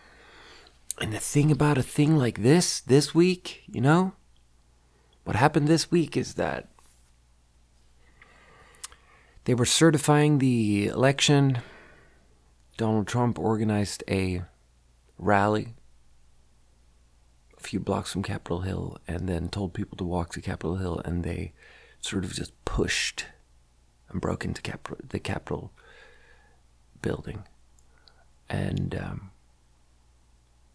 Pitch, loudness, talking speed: 85 Hz, -26 LUFS, 115 wpm